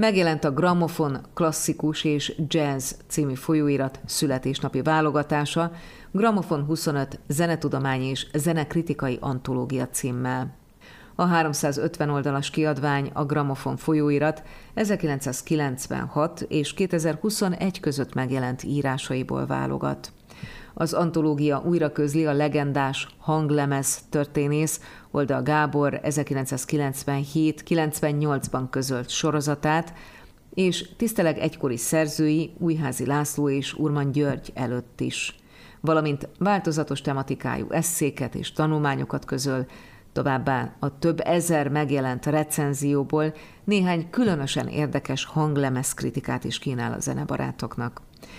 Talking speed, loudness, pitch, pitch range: 95 wpm, -25 LUFS, 150 Hz, 135-160 Hz